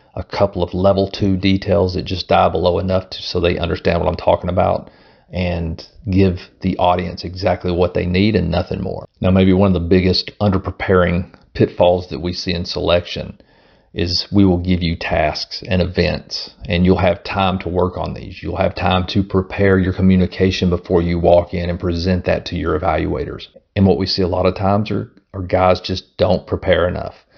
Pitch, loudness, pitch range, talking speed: 90 Hz, -17 LUFS, 90-95 Hz, 200 wpm